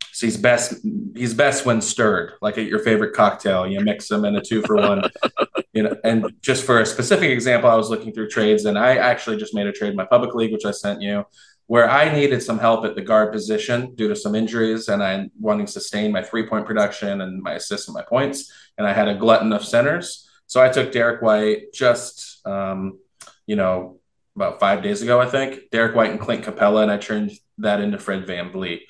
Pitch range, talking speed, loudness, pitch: 105-120 Hz, 230 wpm, -20 LUFS, 110 Hz